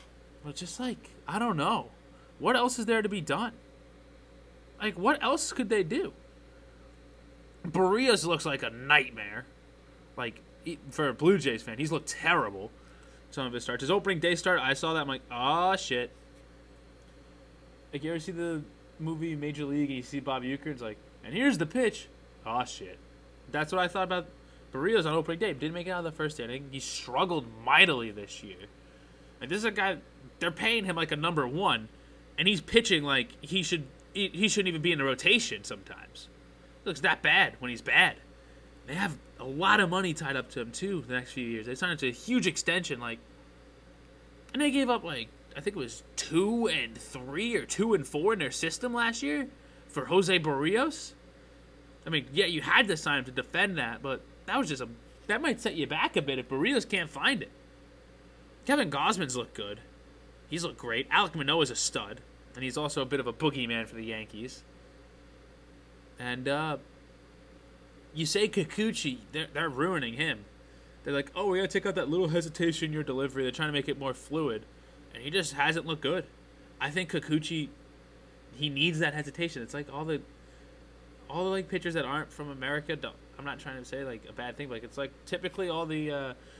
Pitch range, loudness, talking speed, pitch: 125-185 Hz, -30 LUFS, 205 wpm, 150 Hz